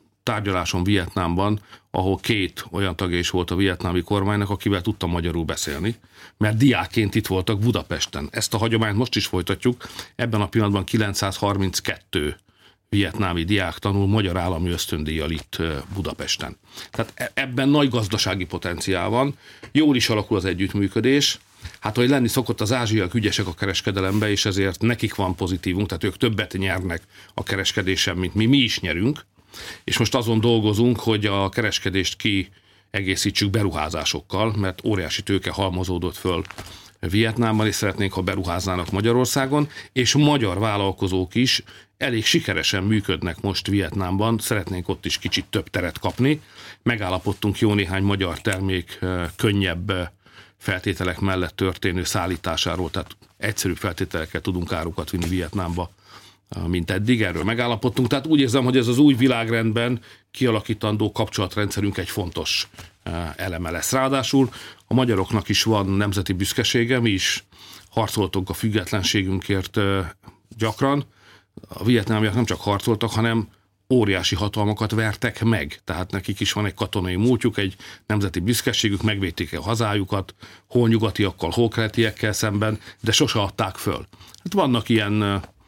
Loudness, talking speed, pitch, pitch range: -22 LUFS, 135 wpm, 100 Hz, 95-115 Hz